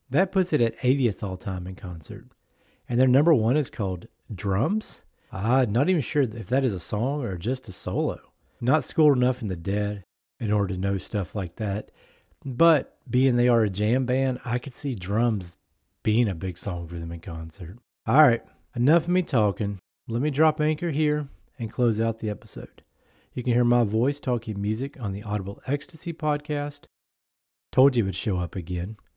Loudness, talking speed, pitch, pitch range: -25 LUFS, 200 wpm, 115 Hz, 100-135 Hz